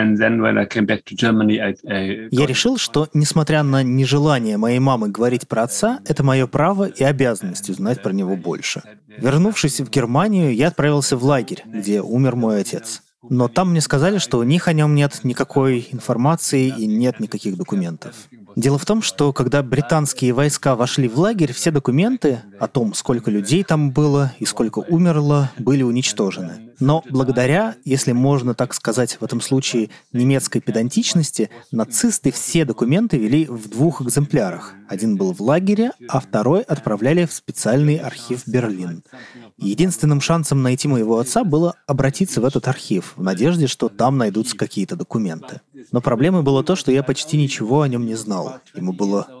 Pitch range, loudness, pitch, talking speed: 120-155 Hz, -18 LUFS, 135 Hz, 160 wpm